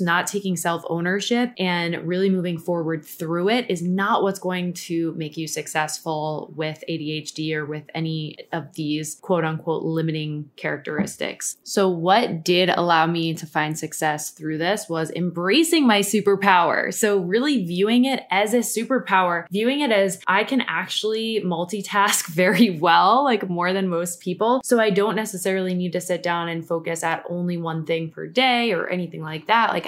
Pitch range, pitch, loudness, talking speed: 165-205 Hz, 175 Hz, -22 LUFS, 170 wpm